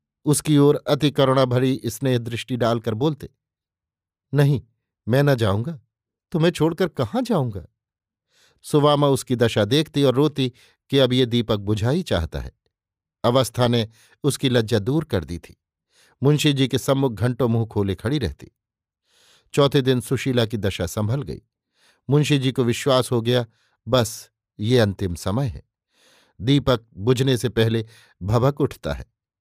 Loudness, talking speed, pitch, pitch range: -21 LUFS, 145 wpm, 125 Hz, 110-140 Hz